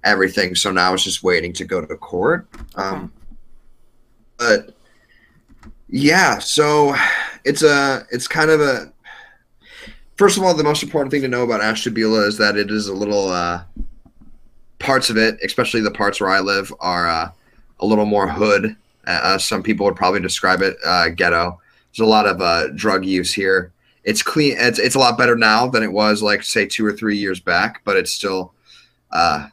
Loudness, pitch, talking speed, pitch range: -17 LUFS, 110 Hz, 185 wpm, 100-125 Hz